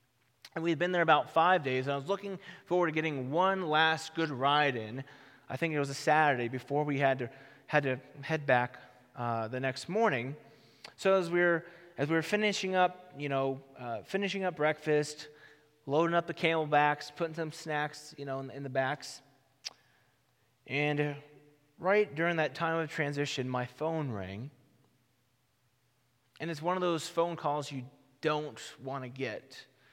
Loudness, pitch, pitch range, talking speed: -32 LUFS, 150 Hz, 130-165 Hz, 175 wpm